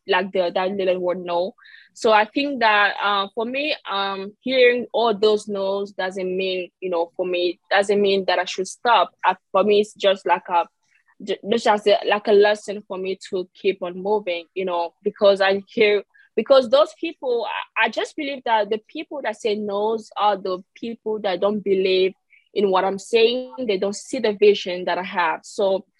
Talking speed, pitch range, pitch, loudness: 190 wpm, 185-220 Hz, 200 Hz, -21 LUFS